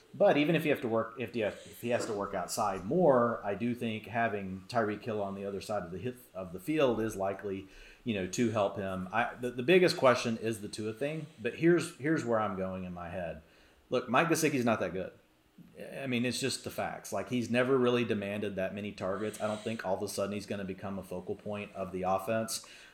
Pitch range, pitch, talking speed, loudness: 95-120 Hz, 110 Hz, 235 wpm, -32 LUFS